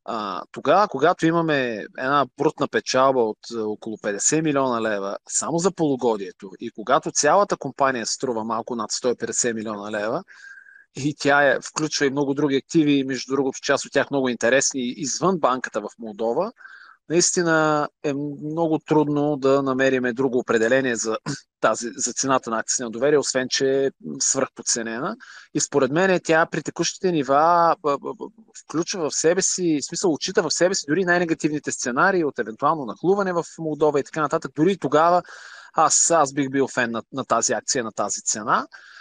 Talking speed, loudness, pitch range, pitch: 160 wpm, -22 LUFS, 130-165 Hz, 145 Hz